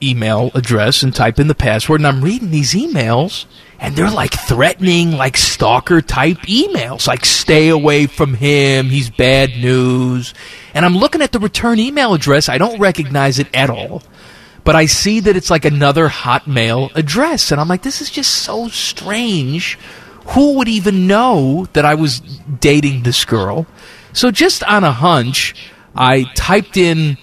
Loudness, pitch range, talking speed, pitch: -13 LUFS, 130-195 Hz, 170 wpm, 150 Hz